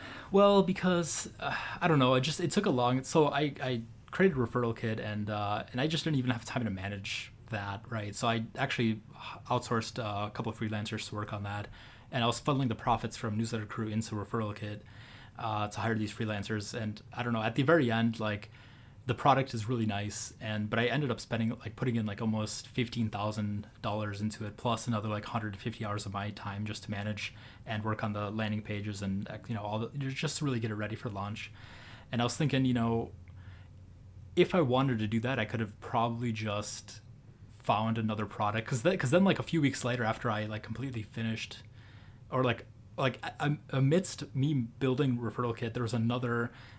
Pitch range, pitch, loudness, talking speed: 105-125 Hz, 115 Hz, -32 LUFS, 210 wpm